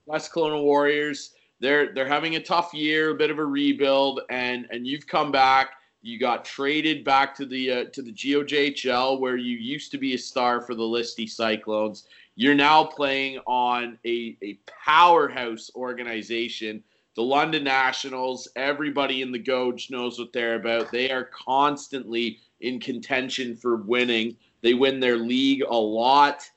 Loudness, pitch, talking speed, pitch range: -24 LUFS, 130 Hz, 165 wpm, 120-145 Hz